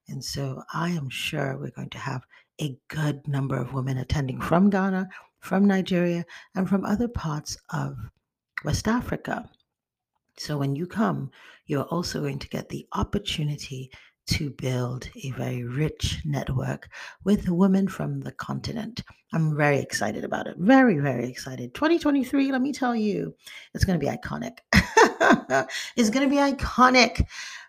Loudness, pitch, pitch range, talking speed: -25 LUFS, 155 Hz, 135-200 Hz, 155 wpm